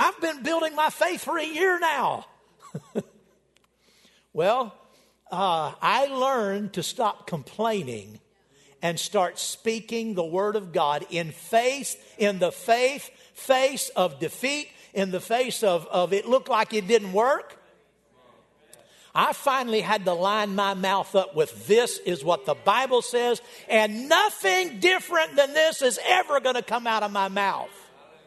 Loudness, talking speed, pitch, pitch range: -24 LUFS, 150 wpm, 225 Hz, 190-270 Hz